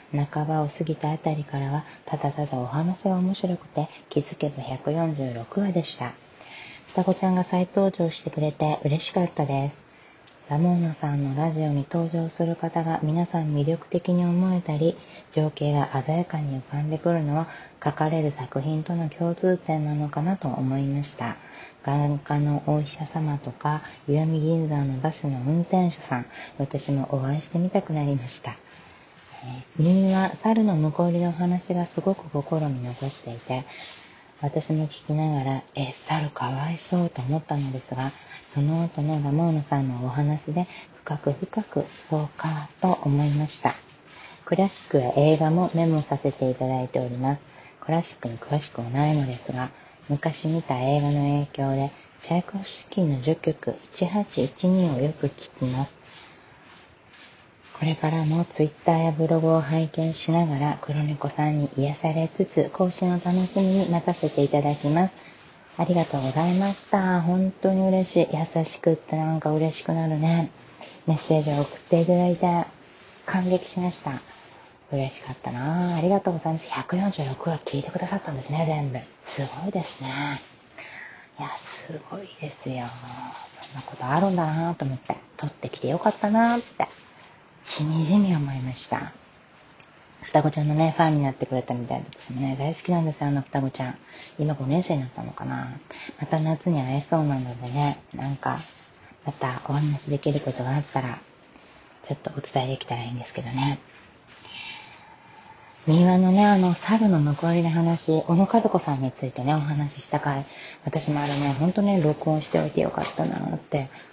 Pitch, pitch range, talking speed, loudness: 155 Hz, 140-170 Hz, 325 characters per minute, -25 LUFS